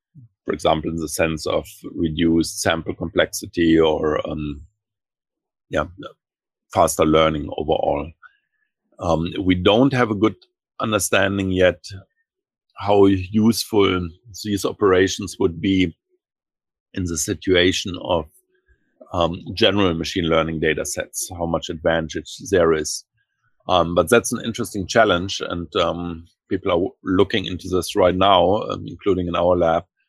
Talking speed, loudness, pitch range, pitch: 125 wpm, -20 LUFS, 85-110 Hz, 95 Hz